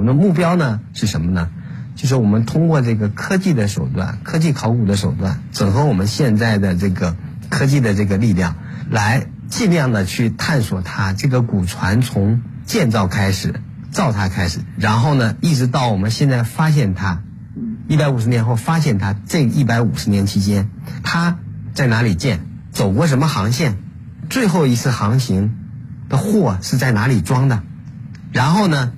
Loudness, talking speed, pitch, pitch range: -17 LUFS, 260 characters per minute, 120 Hz, 105-145 Hz